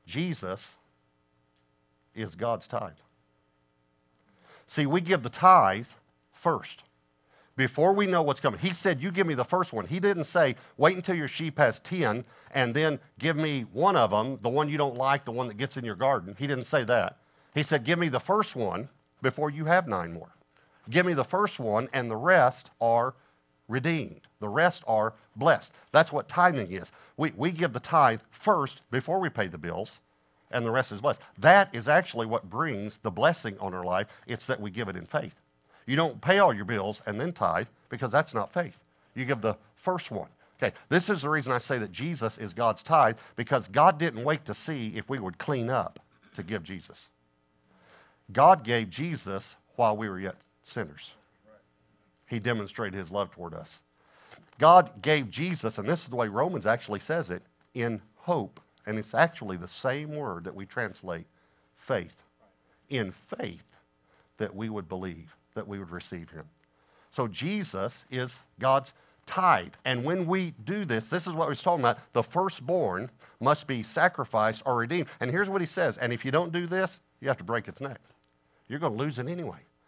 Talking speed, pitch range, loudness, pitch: 195 wpm, 105-160 Hz, -28 LUFS, 125 Hz